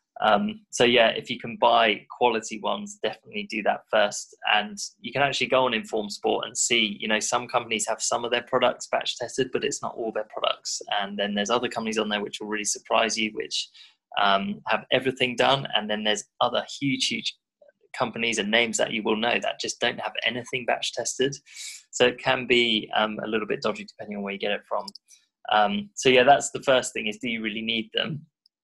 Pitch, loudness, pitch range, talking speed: 115 Hz, -25 LUFS, 105-130 Hz, 220 wpm